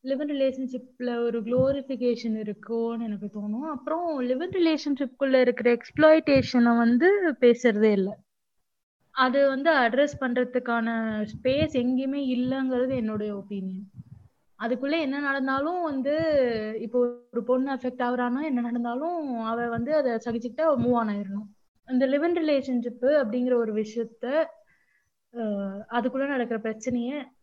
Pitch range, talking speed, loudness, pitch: 230-275 Hz, 110 wpm, -26 LUFS, 250 Hz